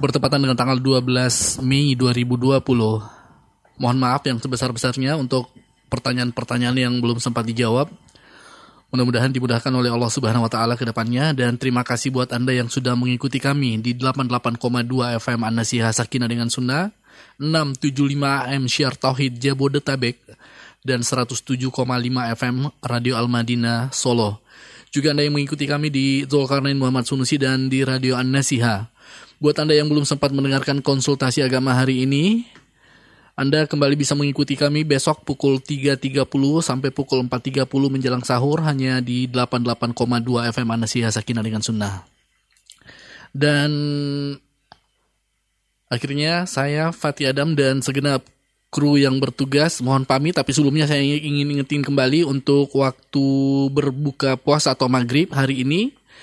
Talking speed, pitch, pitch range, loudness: 130 wpm, 130 Hz, 125-140 Hz, -20 LUFS